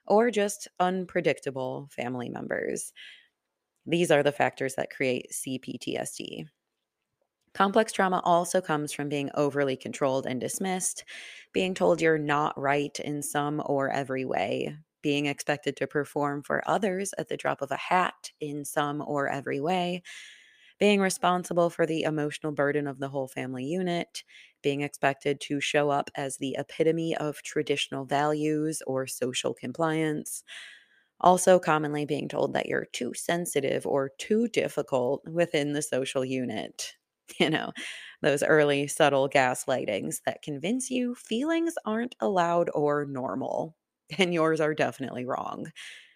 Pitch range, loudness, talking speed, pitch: 140-175 Hz, -28 LUFS, 140 wpm, 150 Hz